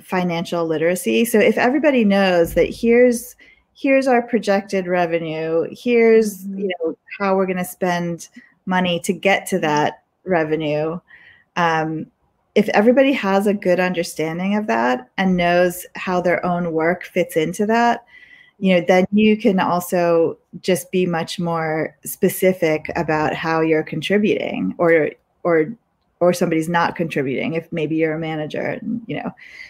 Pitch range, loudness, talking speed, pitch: 165-205 Hz, -19 LUFS, 145 wpm, 180 Hz